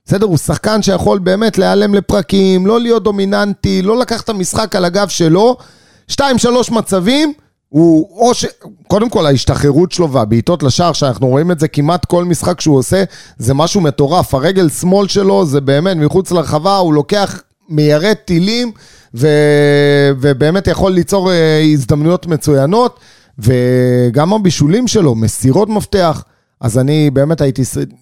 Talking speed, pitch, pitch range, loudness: 145 wpm, 175 Hz, 145-200 Hz, -12 LUFS